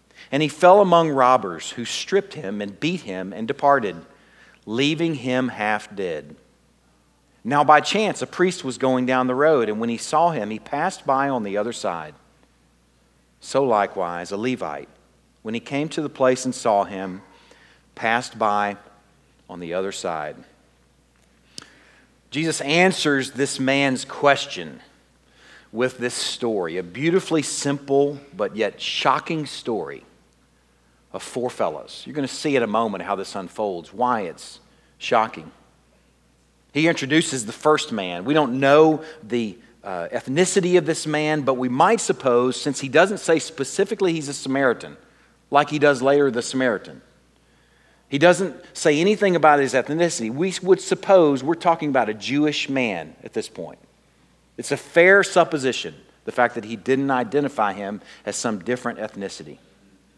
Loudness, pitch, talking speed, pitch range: -21 LUFS, 135 Hz, 155 wpm, 110-155 Hz